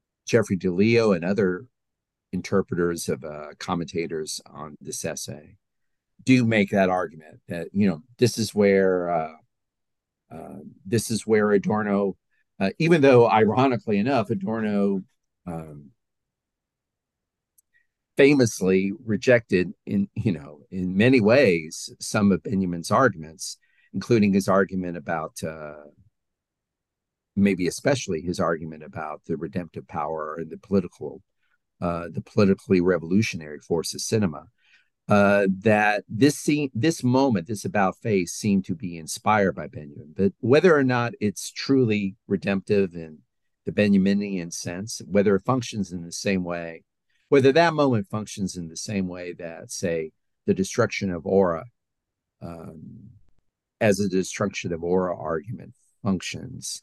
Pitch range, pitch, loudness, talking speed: 90-110 Hz, 100 Hz, -23 LUFS, 130 wpm